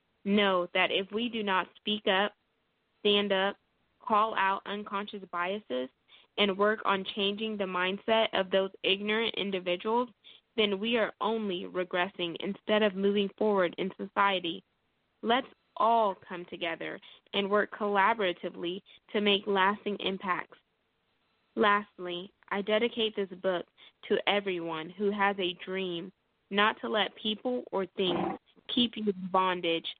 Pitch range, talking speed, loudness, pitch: 185-210 Hz, 135 wpm, -30 LUFS, 200 Hz